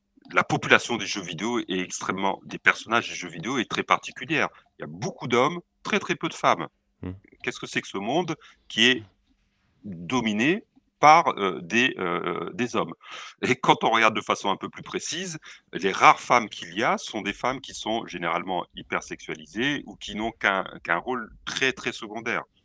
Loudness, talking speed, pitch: -25 LUFS, 190 wpm, 130 Hz